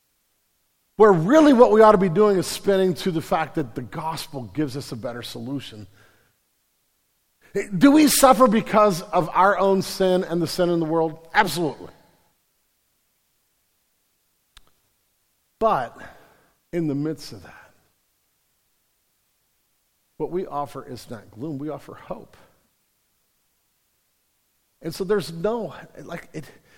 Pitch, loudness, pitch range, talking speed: 165 Hz, -20 LUFS, 130-195 Hz, 130 wpm